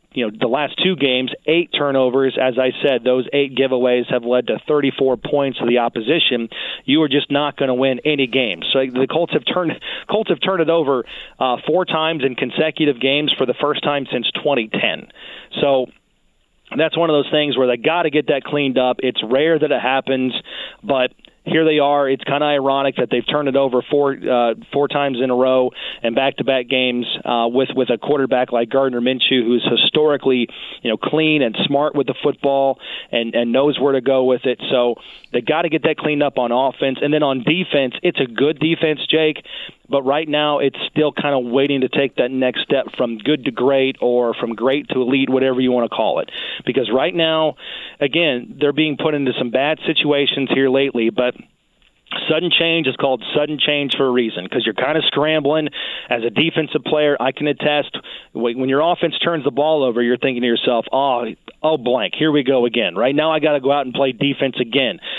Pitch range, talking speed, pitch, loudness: 130-150 Hz, 215 wpm, 135 Hz, -17 LUFS